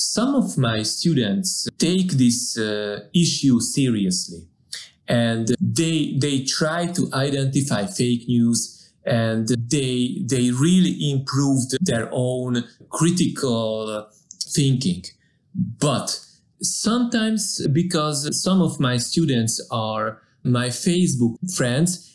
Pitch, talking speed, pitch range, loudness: 135 Hz, 100 wpm, 120-170 Hz, -21 LUFS